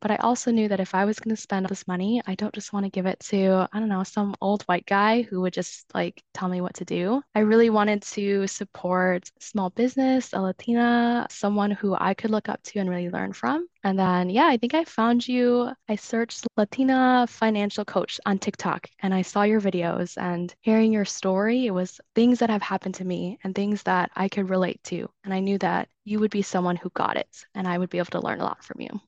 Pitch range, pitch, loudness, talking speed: 190-225 Hz, 205 Hz, -25 LUFS, 245 wpm